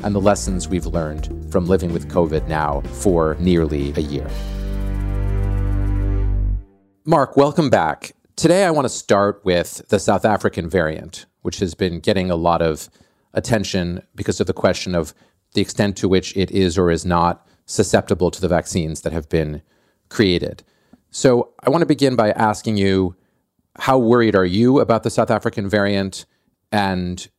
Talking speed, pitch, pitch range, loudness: 165 wpm, 95 Hz, 85-105 Hz, -19 LUFS